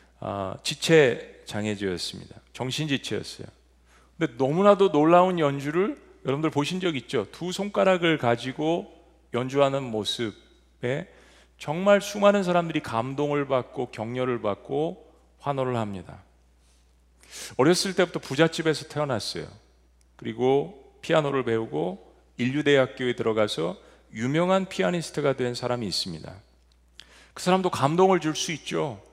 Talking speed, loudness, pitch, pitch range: 295 characters per minute, -25 LUFS, 135 Hz, 110-165 Hz